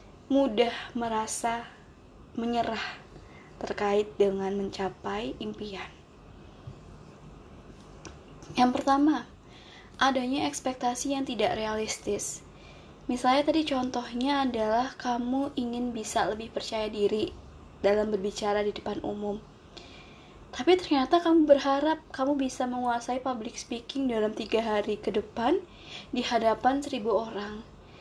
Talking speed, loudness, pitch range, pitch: 100 wpm, -29 LUFS, 215-270 Hz, 240 Hz